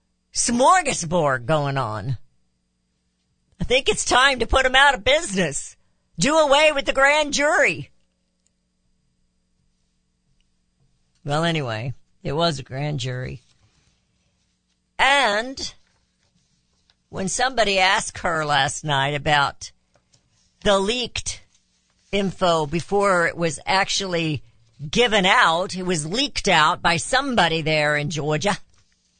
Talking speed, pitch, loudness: 105 wpm, 155 Hz, -20 LUFS